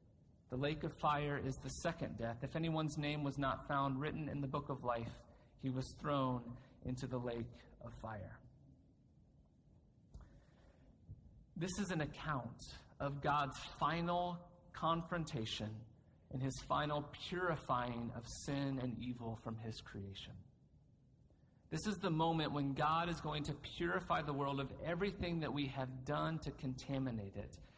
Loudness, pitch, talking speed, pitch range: -42 LUFS, 140 Hz, 145 wpm, 125-155 Hz